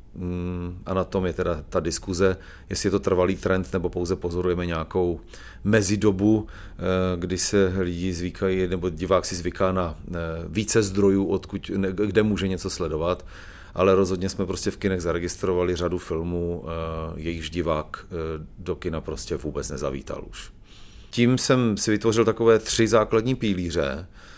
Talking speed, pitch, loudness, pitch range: 145 wpm, 95 Hz, -25 LUFS, 90-100 Hz